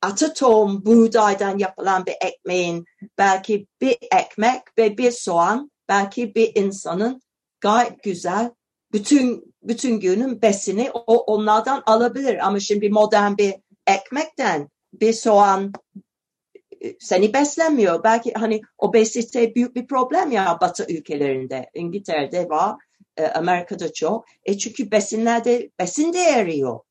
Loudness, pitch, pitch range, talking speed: -20 LUFS, 215 Hz, 195-240 Hz, 110 wpm